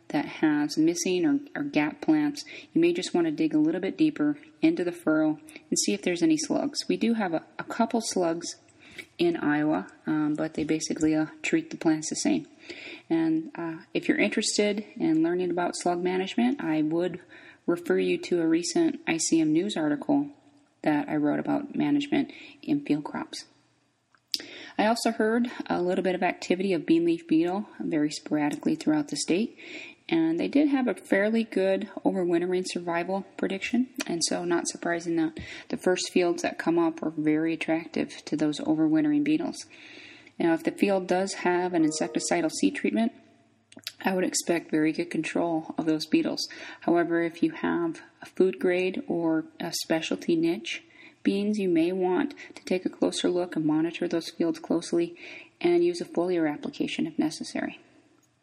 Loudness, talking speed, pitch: -27 LUFS, 175 wpm, 295 Hz